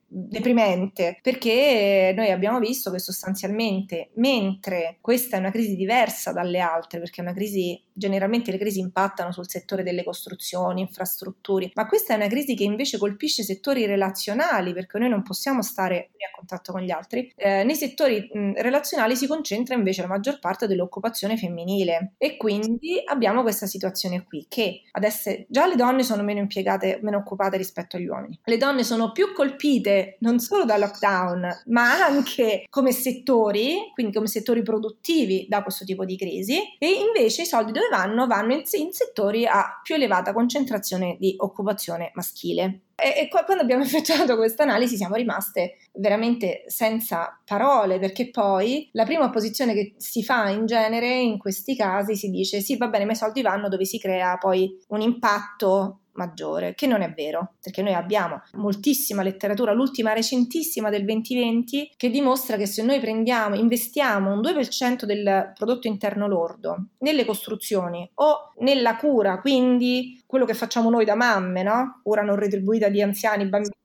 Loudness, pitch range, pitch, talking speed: -23 LUFS, 195-245 Hz, 215 Hz, 165 wpm